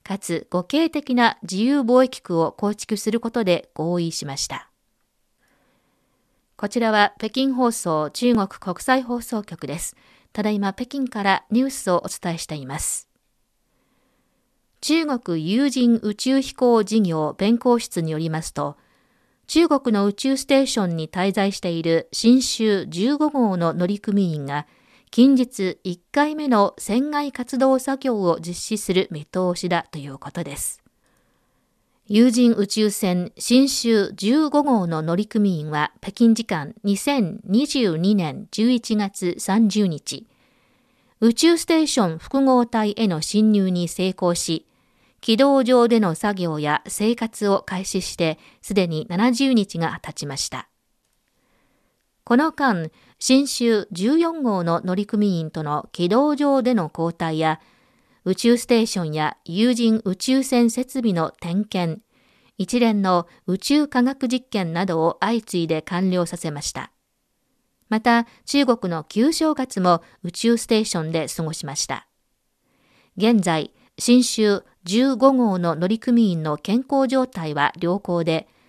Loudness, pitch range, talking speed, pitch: -21 LUFS, 175-245 Hz, 230 characters per minute, 210 Hz